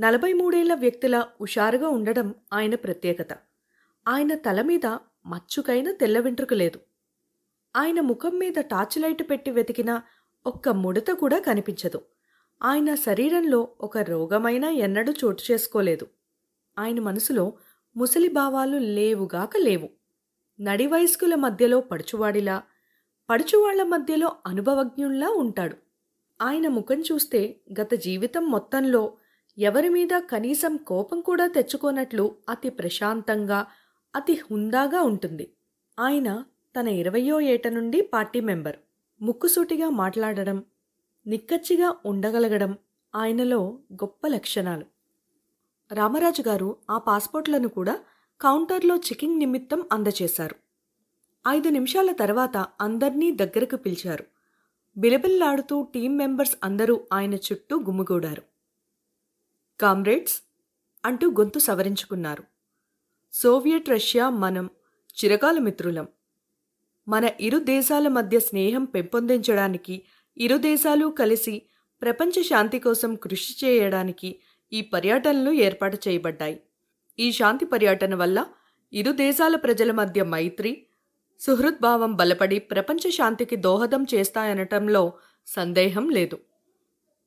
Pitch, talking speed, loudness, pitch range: 235 Hz, 95 wpm, -24 LUFS, 205-285 Hz